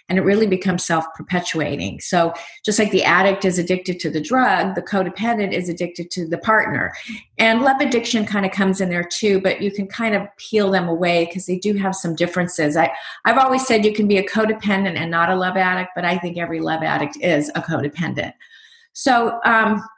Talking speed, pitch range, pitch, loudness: 210 wpm, 175-215 Hz, 190 Hz, -19 LUFS